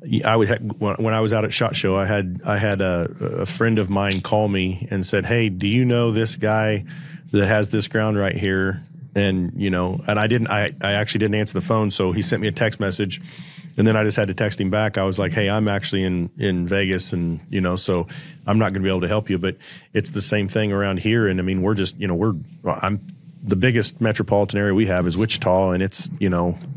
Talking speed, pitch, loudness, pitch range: 255 wpm, 105 Hz, -21 LUFS, 95-110 Hz